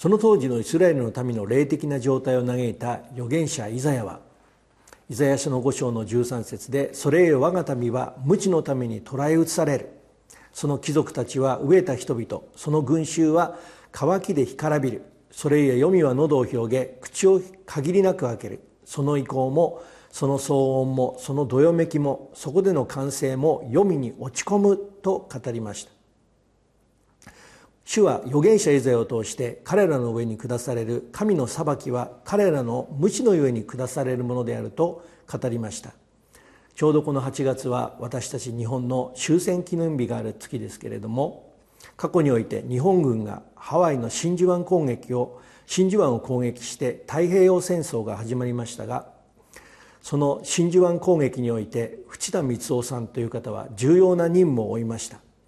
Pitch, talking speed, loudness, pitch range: 135 Hz, 320 characters per minute, -23 LUFS, 120-165 Hz